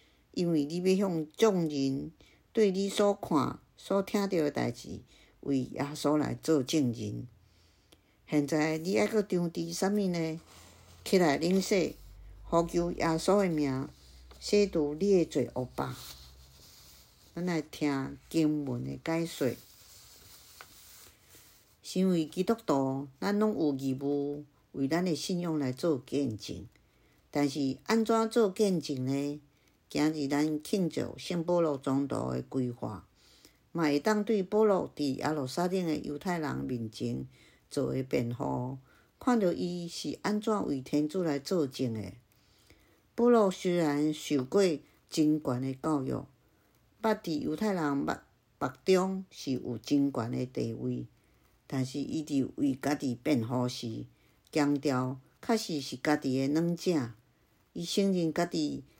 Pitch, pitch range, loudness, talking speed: 145 Hz, 125-175 Hz, -31 LUFS, 185 characters per minute